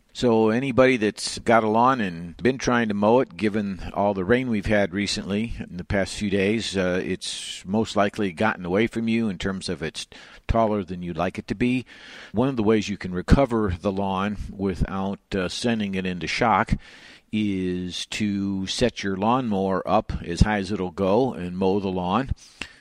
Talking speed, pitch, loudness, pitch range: 195 wpm, 100 Hz, -24 LUFS, 95-110 Hz